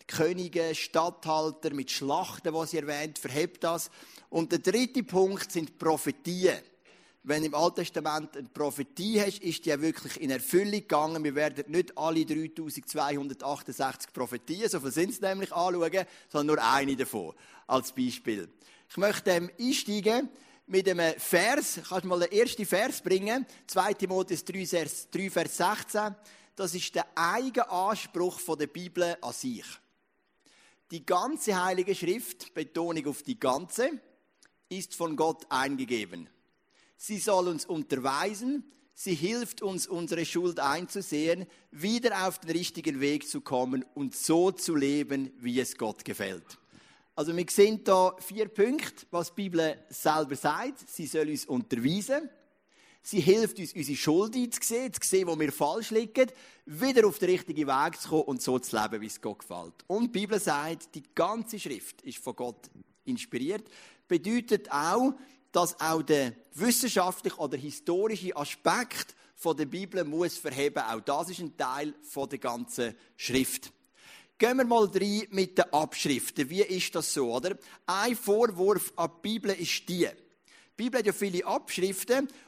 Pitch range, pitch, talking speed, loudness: 150-205 Hz, 175 Hz, 155 wpm, -30 LUFS